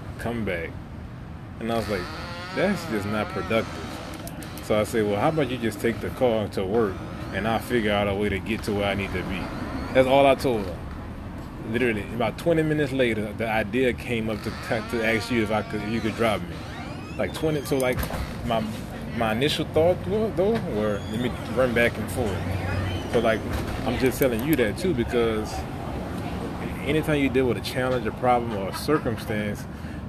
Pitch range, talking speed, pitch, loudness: 100-125 Hz, 200 wpm, 110 Hz, -25 LUFS